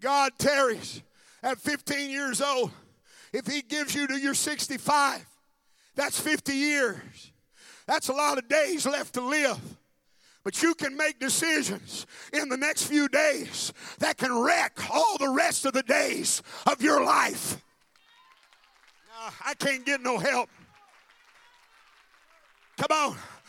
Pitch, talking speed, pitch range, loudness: 280 Hz, 140 wpm, 270-300 Hz, -26 LUFS